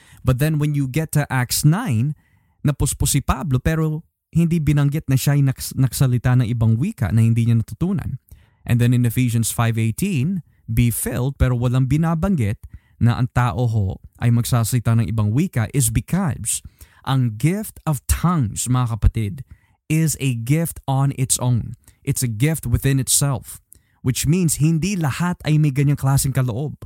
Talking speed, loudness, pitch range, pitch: 160 wpm, -20 LUFS, 115-150 Hz, 130 Hz